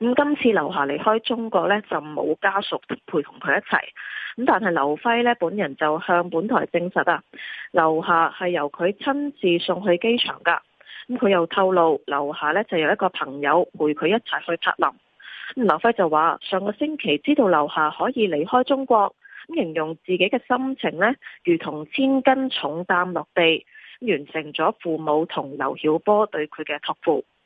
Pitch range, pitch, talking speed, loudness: 155-230 Hz, 180 Hz, 255 characters per minute, -22 LUFS